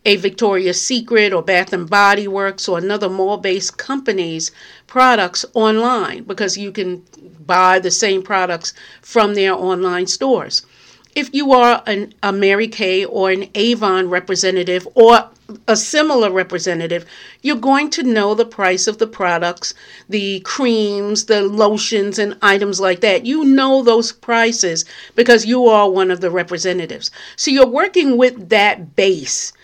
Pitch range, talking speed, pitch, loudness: 185-230 Hz, 150 wpm, 205 Hz, -15 LUFS